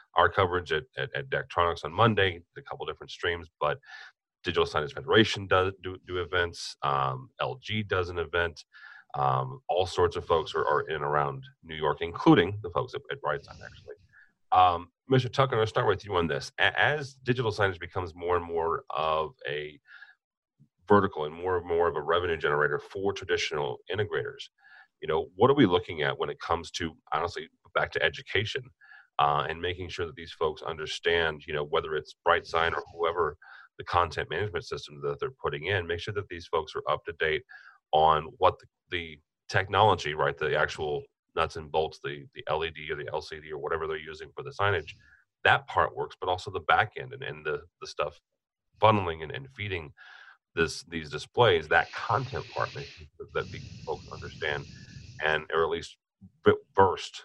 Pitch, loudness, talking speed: 395 Hz, -29 LUFS, 190 wpm